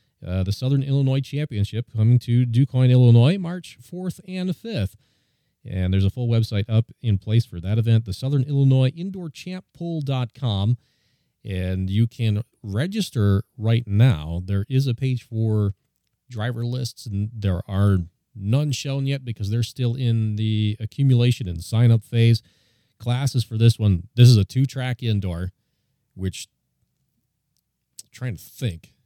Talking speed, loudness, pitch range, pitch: 150 wpm, -22 LUFS, 105-130 Hz, 115 Hz